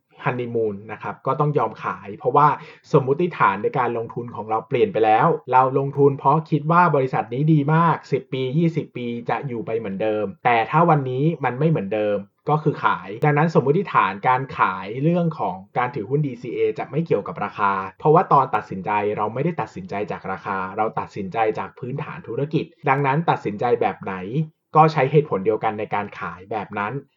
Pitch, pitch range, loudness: 140 Hz, 120-155 Hz, -21 LUFS